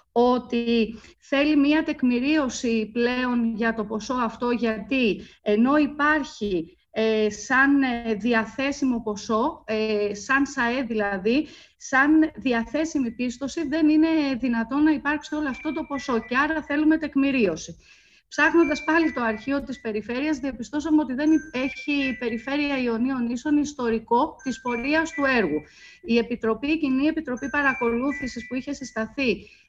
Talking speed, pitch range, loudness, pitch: 130 wpm, 230-295 Hz, -24 LUFS, 260 Hz